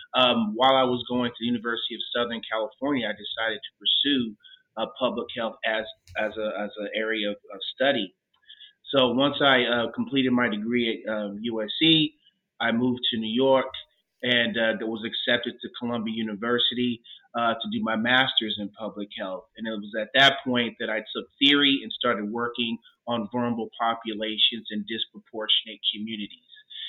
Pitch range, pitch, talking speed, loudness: 110-135 Hz, 120 Hz, 170 wpm, -25 LUFS